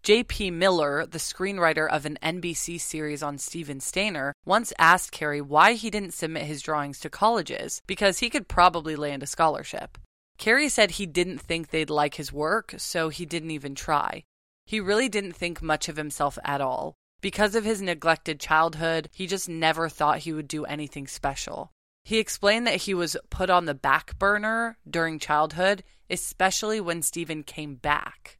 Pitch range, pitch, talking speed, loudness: 150-195 Hz, 165 Hz, 175 wpm, -26 LUFS